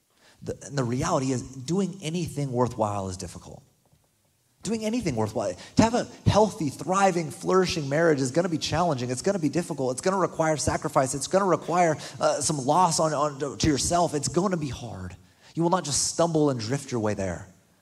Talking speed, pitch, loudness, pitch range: 200 wpm, 150 Hz, -25 LUFS, 125-170 Hz